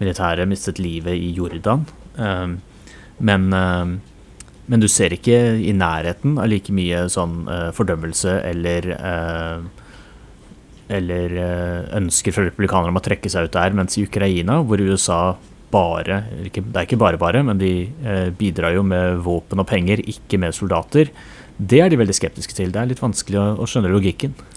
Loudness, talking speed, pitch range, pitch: -19 LUFS, 155 wpm, 90-105 Hz, 95 Hz